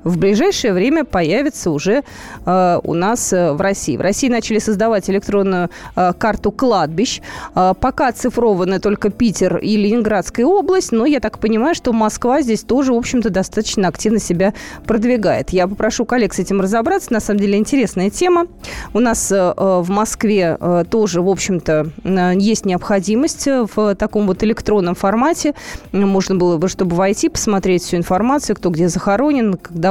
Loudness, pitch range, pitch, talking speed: -16 LUFS, 185-235 Hz, 205 Hz, 165 wpm